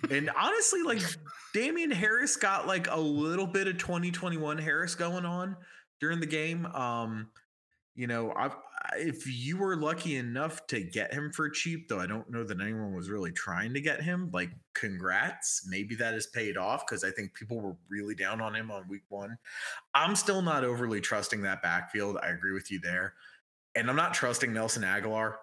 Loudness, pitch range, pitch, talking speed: -32 LUFS, 110-170 Hz, 140 Hz, 190 wpm